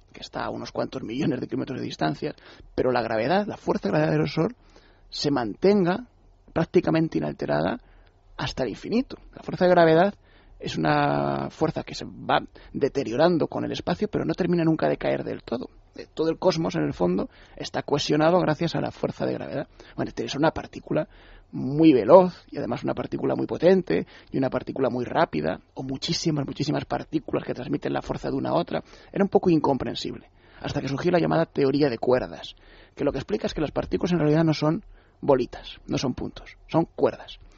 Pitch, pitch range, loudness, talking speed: 160 Hz, 140-180 Hz, -25 LUFS, 195 wpm